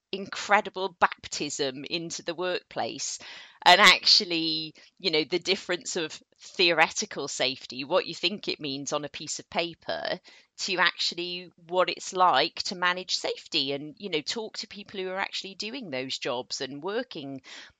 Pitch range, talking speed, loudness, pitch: 155-195 Hz, 155 wpm, -26 LUFS, 180 Hz